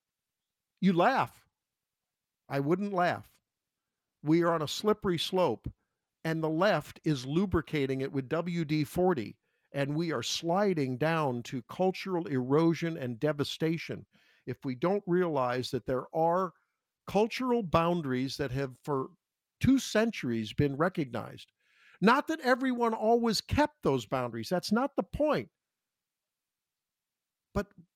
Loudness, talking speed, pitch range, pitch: -30 LUFS, 125 wpm, 135-190 Hz, 165 Hz